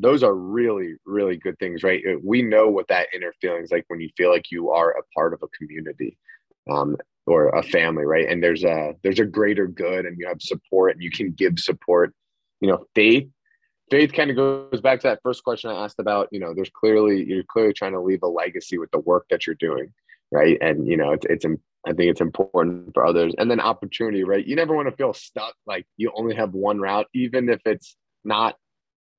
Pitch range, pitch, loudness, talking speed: 90-125 Hz, 105 Hz, -21 LUFS, 230 wpm